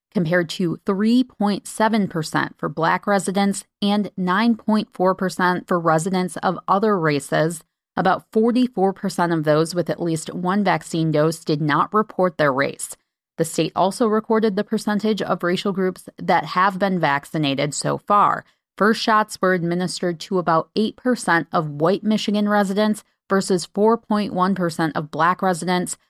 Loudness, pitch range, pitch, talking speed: -20 LUFS, 170-210 Hz, 185 Hz, 135 wpm